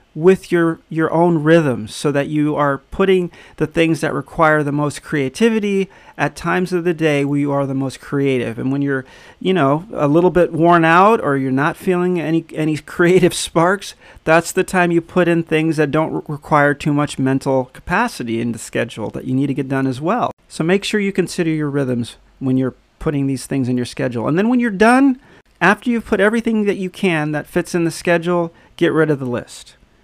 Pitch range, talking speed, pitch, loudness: 140-180 Hz, 220 wpm, 160 Hz, -17 LUFS